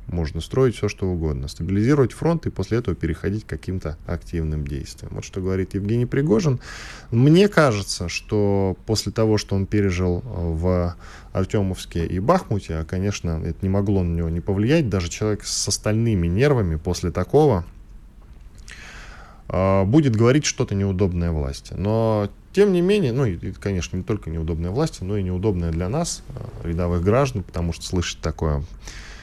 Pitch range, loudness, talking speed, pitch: 85-110 Hz, -22 LUFS, 155 wpm, 95 Hz